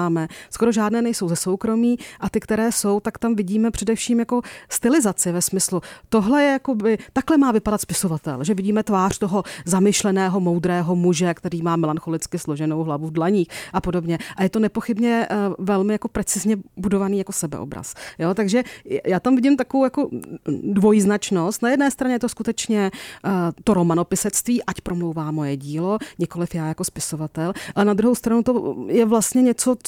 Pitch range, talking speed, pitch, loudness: 175-230 Hz, 165 wpm, 200 Hz, -21 LUFS